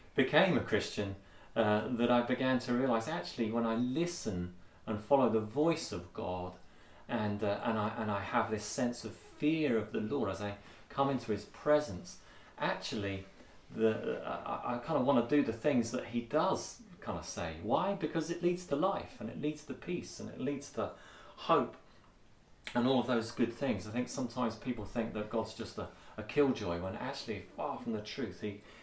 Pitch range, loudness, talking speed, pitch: 105-130 Hz, -35 LUFS, 200 wpm, 115 Hz